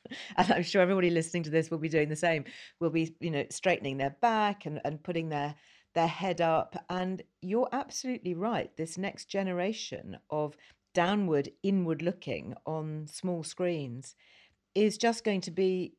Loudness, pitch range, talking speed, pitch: -31 LUFS, 155-195 Hz, 170 wpm, 175 Hz